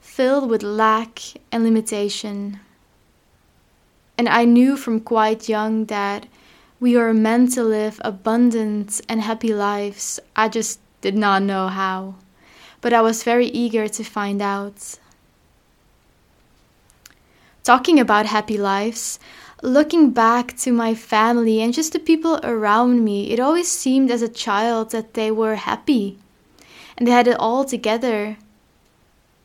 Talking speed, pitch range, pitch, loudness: 135 wpm, 210-240 Hz, 225 Hz, -19 LUFS